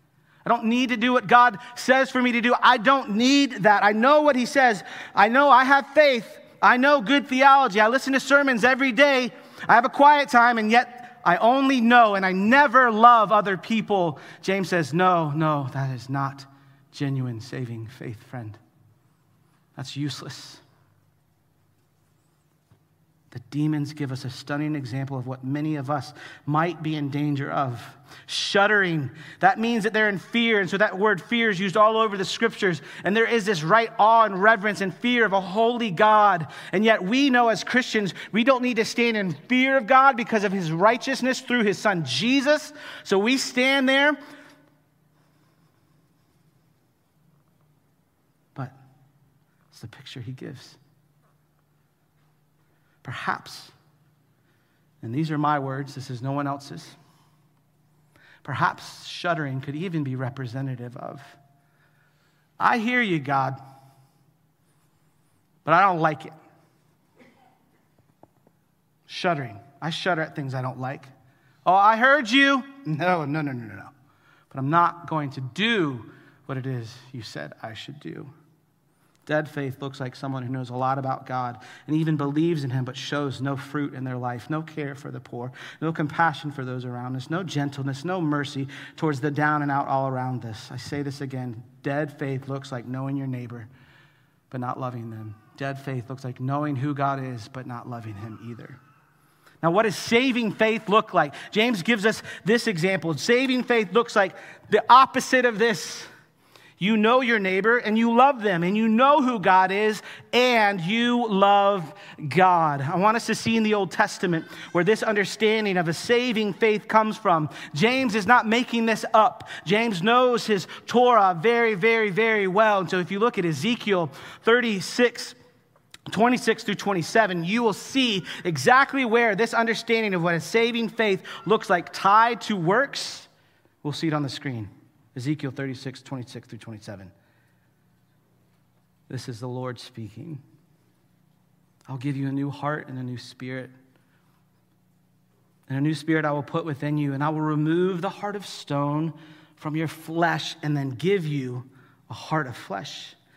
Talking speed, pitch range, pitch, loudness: 170 wpm, 140-220 Hz, 160 Hz, -22 LUFS